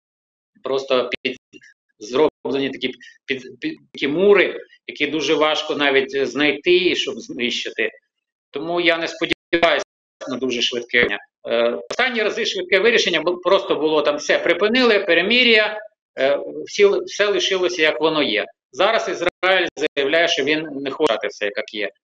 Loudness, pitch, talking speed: -19 LUFS, 175 Hz, 140 wpm